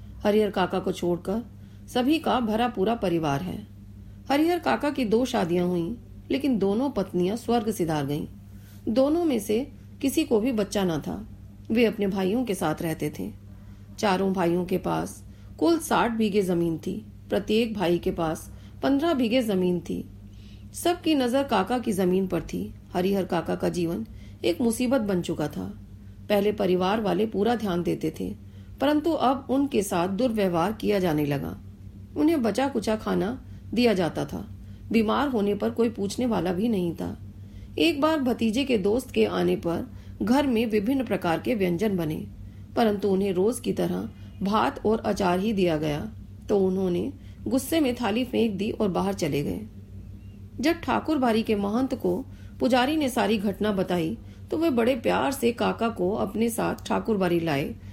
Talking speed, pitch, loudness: 165 wpm, 190 Hz, -26 LUFS